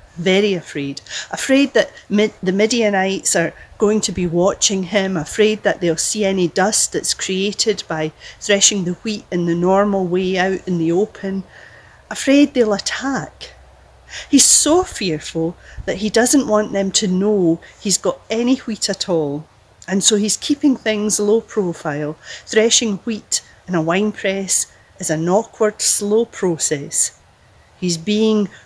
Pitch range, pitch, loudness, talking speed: 175-215 Hz, 200 Hz, -17 LUFS, 150 wpm